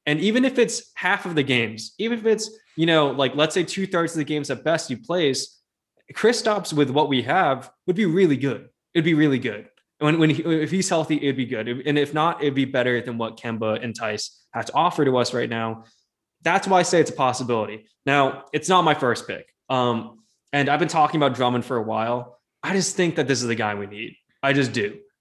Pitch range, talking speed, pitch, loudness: 125-170 Hz, 245 wpm, 145 Hz, -22 LUFS